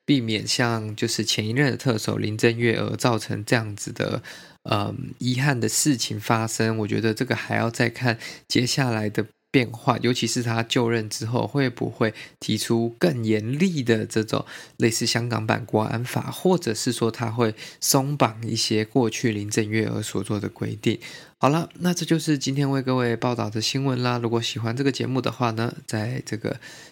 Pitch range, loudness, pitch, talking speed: 110-130 Hz, -24 LUFS, 115 Hz, 275 characters per minute